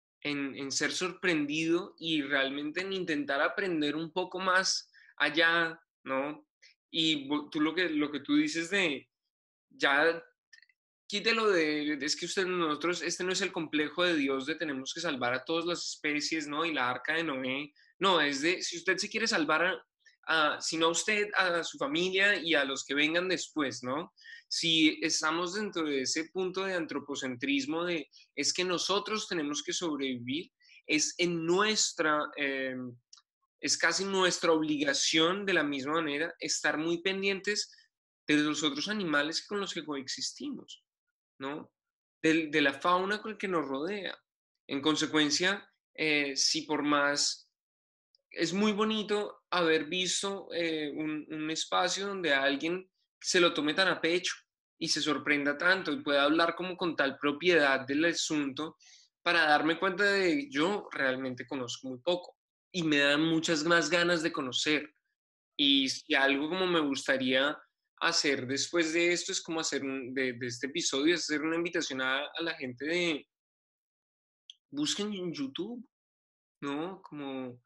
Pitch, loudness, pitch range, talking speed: 165 Hz, -30 LUFS, 145-185 Hz, 160 wpm